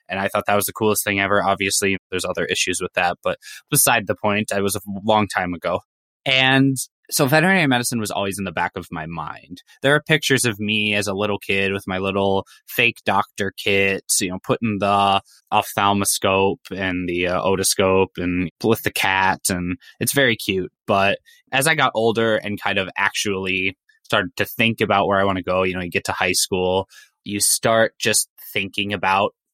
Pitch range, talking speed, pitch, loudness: 95-110 Hz, 200 wpm, 100 Hz, -19 LUFS